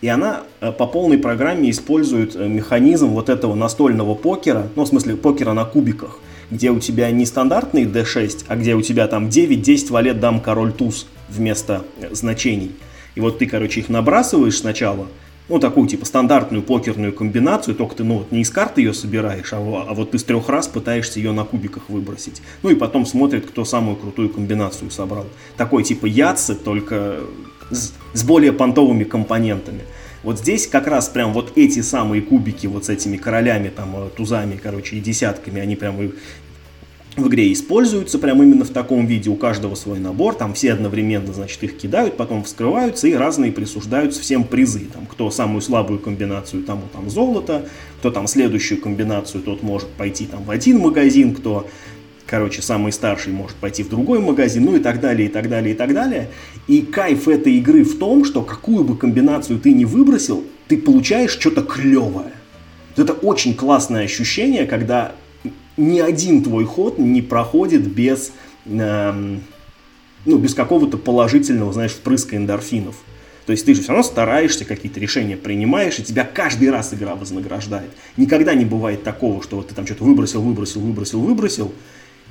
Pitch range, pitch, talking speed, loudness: 105-145 Hz, 115 Hz, 175 wpm, -17 LUFS